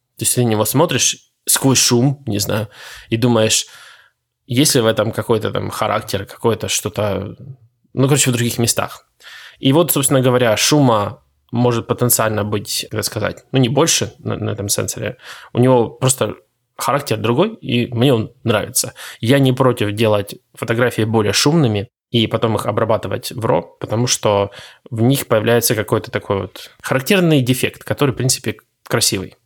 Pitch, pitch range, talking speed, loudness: 120 Hz, 110-130 Hz, 160 wpm, -16 LUFS